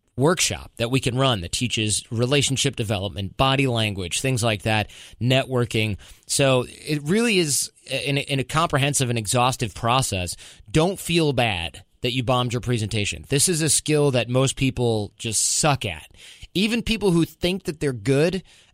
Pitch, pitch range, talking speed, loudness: 125 Hz, 110-145 Hz, 165 wpm, -22 LUFS